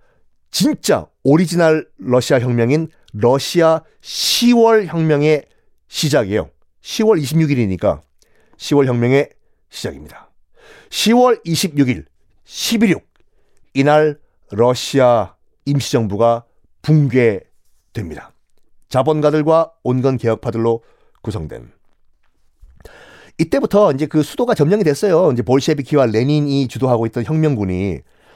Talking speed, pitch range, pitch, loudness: 225 characters per minute, 120-160 Hz, 140 Hz, -16 LUFS